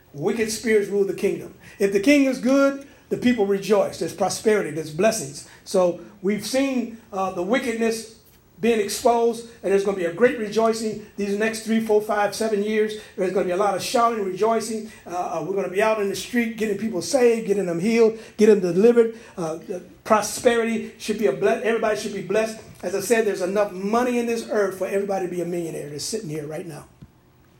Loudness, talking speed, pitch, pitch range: -22 LUFS, 215 wpm, 210 Hz, 190-225 Hz